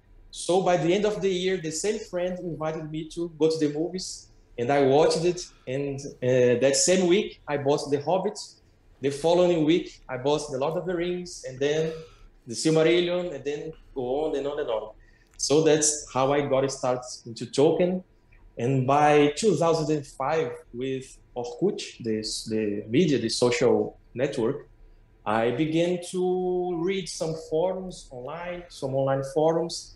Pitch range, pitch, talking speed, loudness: 125-175 Hz, 150 Hz, 160 wpm, -25 LUFS